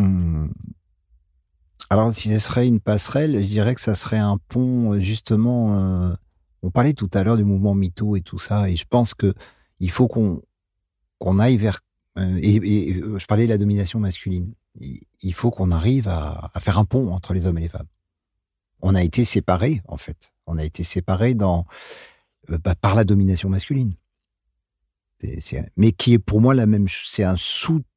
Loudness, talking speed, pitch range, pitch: -20 LUFS, 195 wpm, 90-110 Hz, 100 Hz